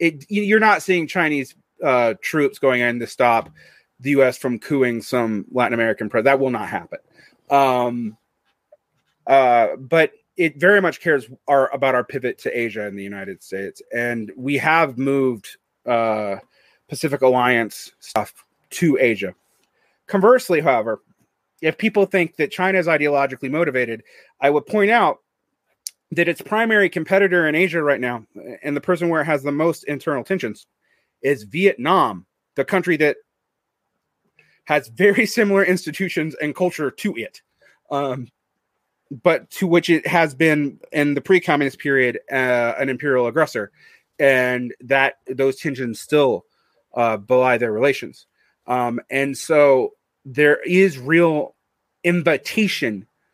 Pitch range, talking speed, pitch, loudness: 125-175 Hz, 140 wpm, 145 Hz, -19 LUFS